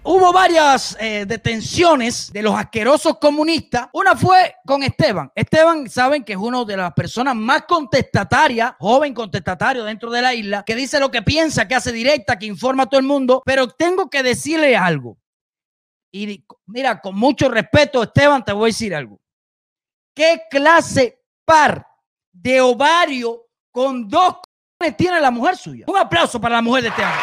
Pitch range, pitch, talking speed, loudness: 230-310 Hz, 260 Hz, 170 wpm, -16 LUFS